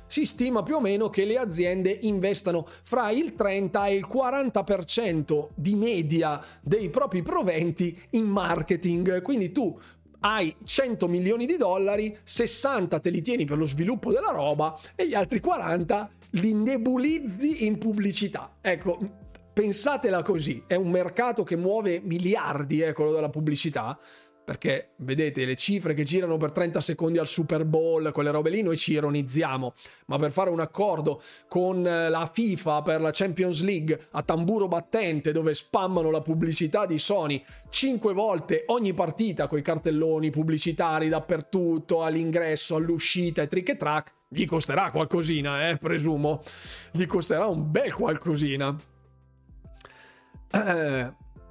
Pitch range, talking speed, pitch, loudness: 155-200 Hz, 145 wpm, 175 Hz, -26 LUFS